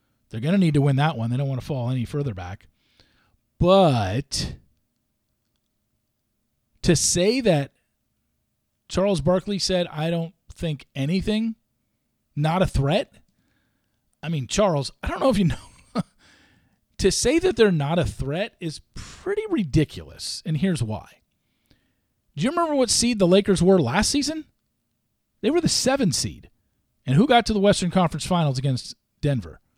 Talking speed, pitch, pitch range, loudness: 155 wpm, 165 Hz, 130-200 Hz, -22 LUFS